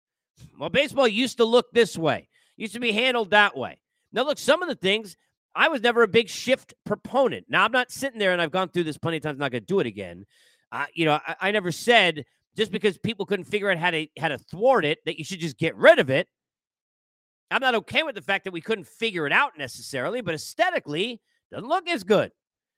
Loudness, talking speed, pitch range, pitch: -23 LUFS, 250 wpm, 165-240 Hz, 205 Hz